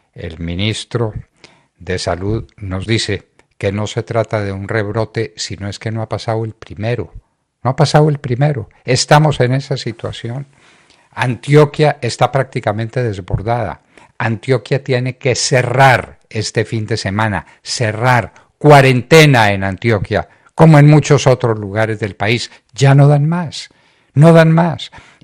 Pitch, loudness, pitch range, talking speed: 115 Hz, -14 LUFS, 105-135 Hz, 145 wpm